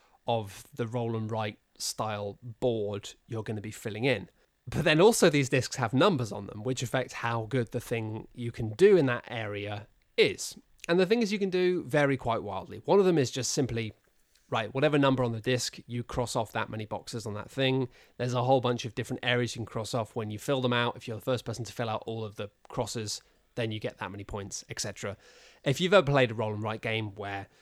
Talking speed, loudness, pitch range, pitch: 240 wpm, -30 LUFS, 110-130 Hz, 120 Hz